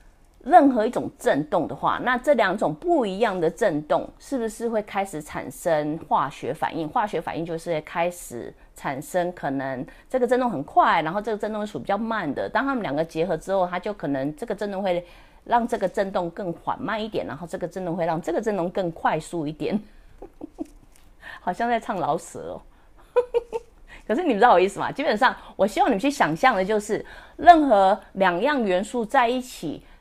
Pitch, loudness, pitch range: 205 Hz, -23 LUFS, 170-250 Hz